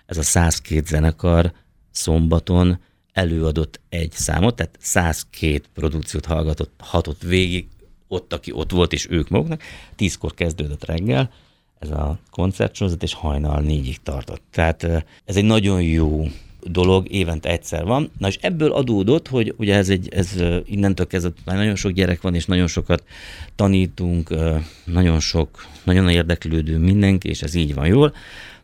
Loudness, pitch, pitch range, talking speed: -20 LUFS, 85 Hz, 80-95 Hz, 145 wpm